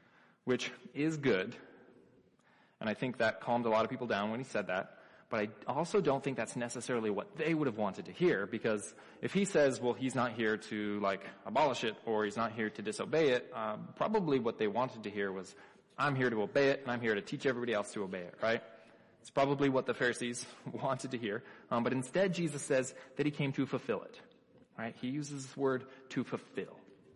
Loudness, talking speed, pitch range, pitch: -35 LUFS, 220 wpm, 115-140 Hz, 125 Hz